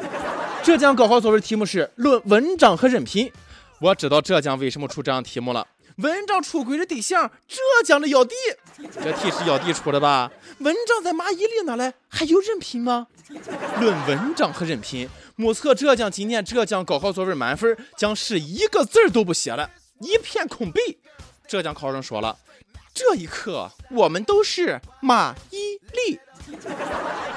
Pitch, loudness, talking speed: 240 Hz, -21 LUFS, 245 characters per minute